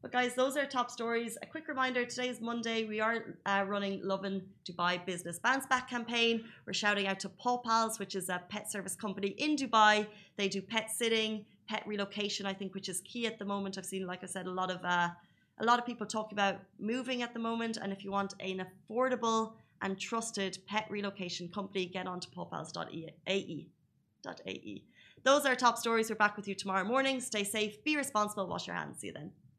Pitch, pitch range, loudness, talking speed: 210 Hz, 195-230 Hz, -34 LUFS, 210 wpm